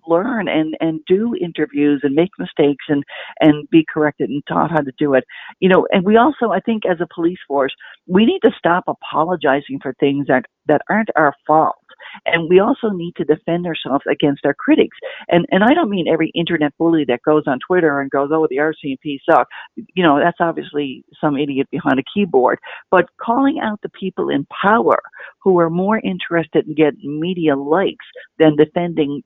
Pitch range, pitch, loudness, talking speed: 145-185 Hz, 160 Hz, -17 LUFS, 195 wpm